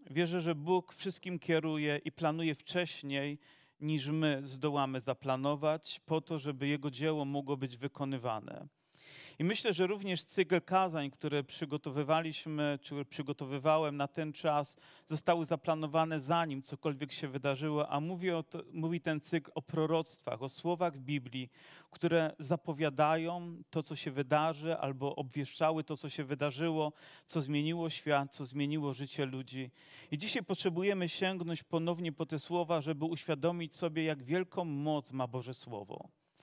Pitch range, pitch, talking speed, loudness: 145-165 Hz, 155 Hz, 145 wpm, -36 LUFS